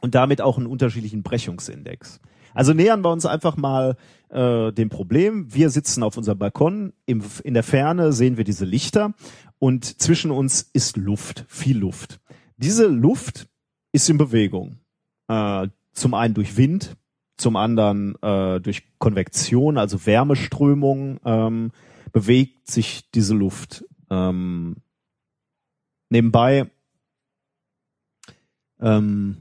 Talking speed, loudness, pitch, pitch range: 120 wpm, -20 LUFS, 125 Hz, 105-140 Hz